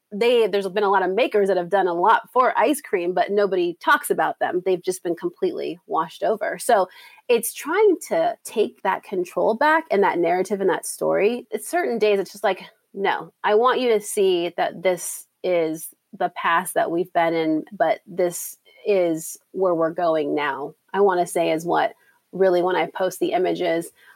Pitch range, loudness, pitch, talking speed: 180-250 Hz, -22 LUFS, 200 Hz, 200 wpm